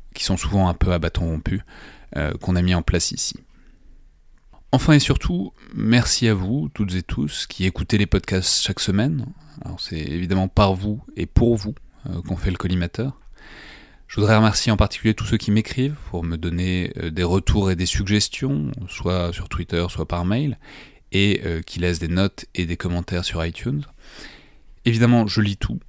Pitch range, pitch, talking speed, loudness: 90-110 Hz, 95 Hz, 190 wpm, -21 LUFS